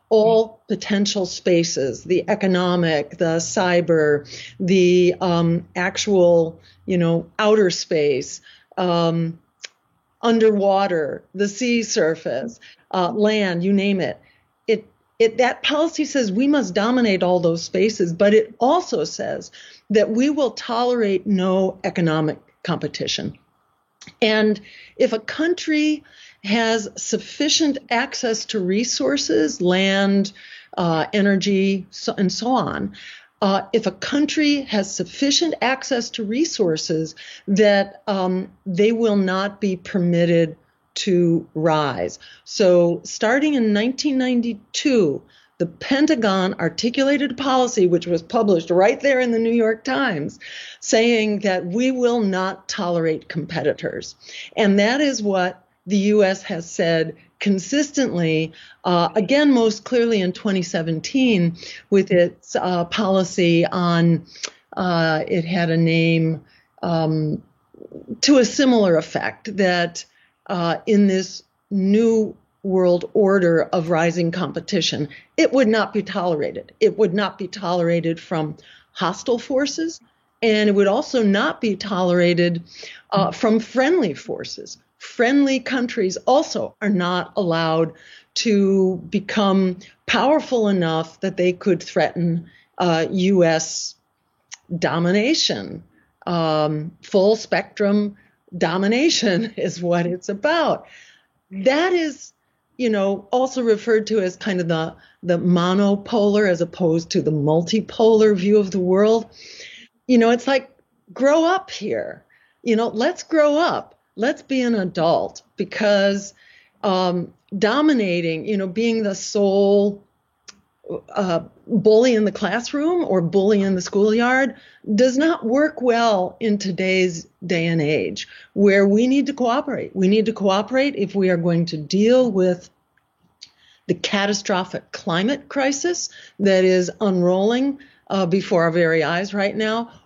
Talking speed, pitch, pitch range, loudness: 125 wpm, 200 Hz, 180-235 Hz, -20 LUFS